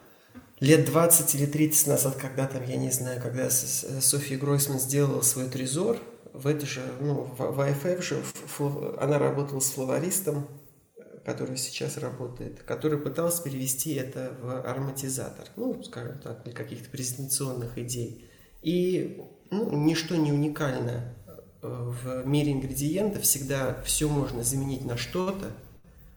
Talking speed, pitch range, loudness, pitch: 130 wpm, 130-150 Hz, -27 LUFS, 135 Hz